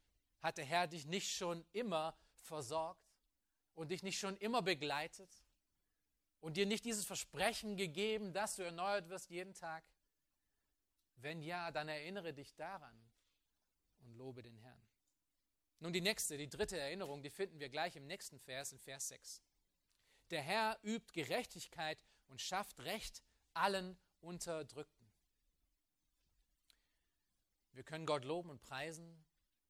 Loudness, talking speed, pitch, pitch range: -43 LUFS, 135 wpm, 160 Hz, 135-190 Hz